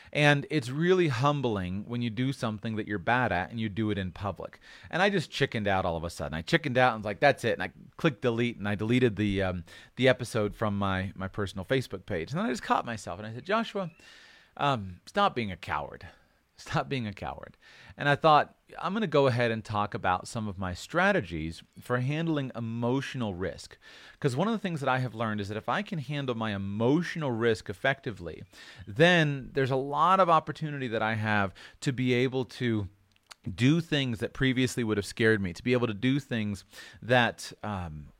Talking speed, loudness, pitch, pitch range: 215 wpm, -29 LUFS, 120 Hz, 105-140 Hz